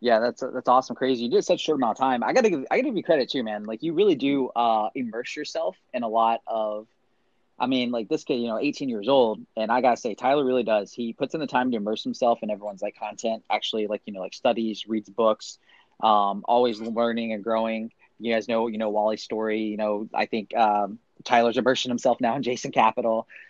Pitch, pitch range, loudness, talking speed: 115 Hz, 110-125 Hz, -25 LUFS, 245 wpm